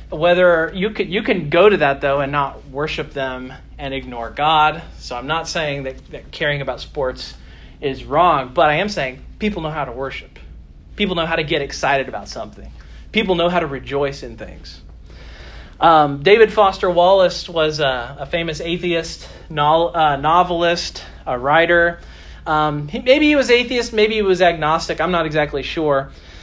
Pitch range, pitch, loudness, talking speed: 135-175 Hz, 155 Hz, -17 LUFS, 180 wpm